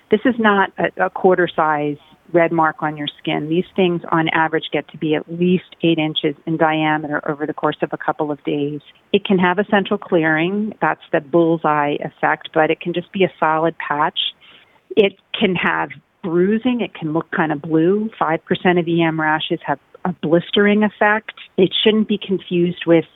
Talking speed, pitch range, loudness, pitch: 190 wpm, 155-190 Hz, -18 LUFS, 170 Hz